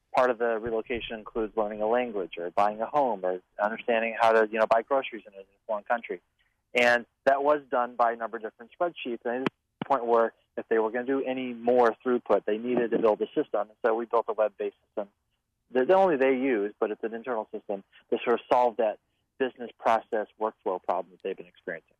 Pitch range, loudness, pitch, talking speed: 110-125 Hz, -28 LUFS, 115 Hz, 220 wpm